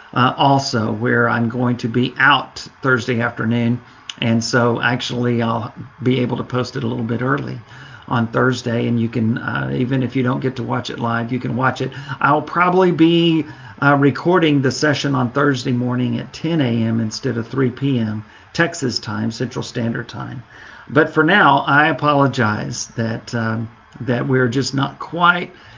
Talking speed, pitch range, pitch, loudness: 175 wpm, 120-140 Hz, 125 Hz, -18 LUFS